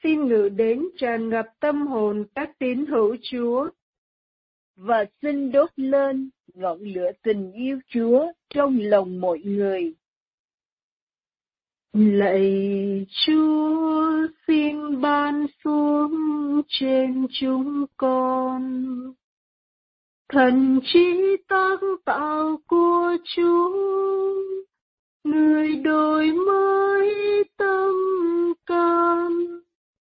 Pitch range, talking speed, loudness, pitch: 250-340 Hz, 85 wpm, -22 LUFS, 290 Hz